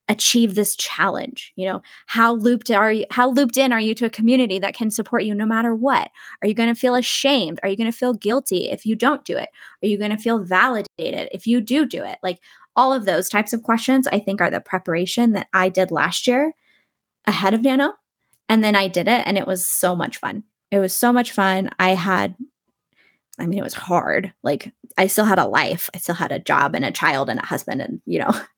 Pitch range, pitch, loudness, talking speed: 190-245 Hz, 220 Hz, -20 LUFS, 240 wpm